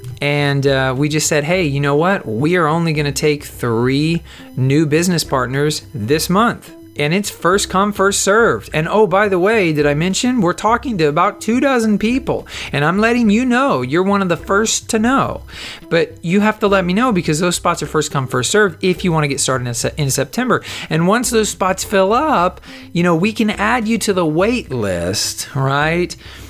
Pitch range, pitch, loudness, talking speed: 145-205 Hz, 170 Hz, -16 LUFS, 215 wpm